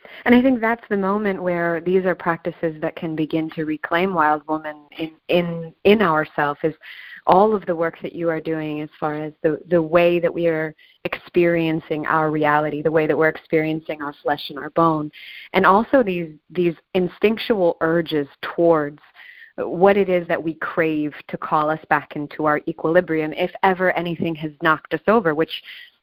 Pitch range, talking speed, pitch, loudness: 155-180 Hz, 190 wpm, 165 Hz, -20 LUFS